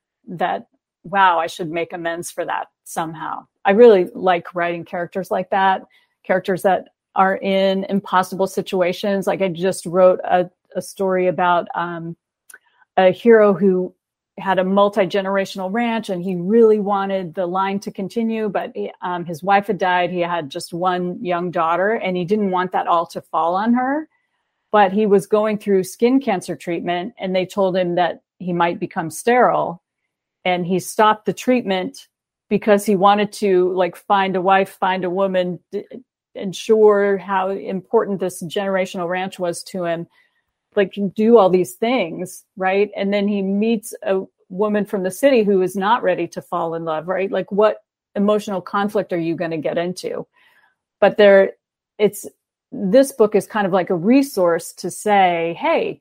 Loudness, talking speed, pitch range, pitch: -19 LUFS, 170 wpm, 180-205 Hz, 190 Hz